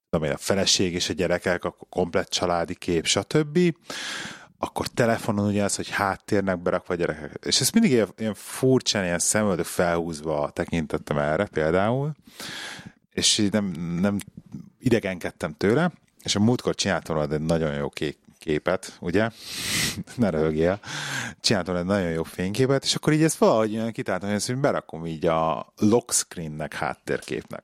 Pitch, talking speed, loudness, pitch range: 95 Hz, 150 wpm, -24 LUFS, 85-115 Hz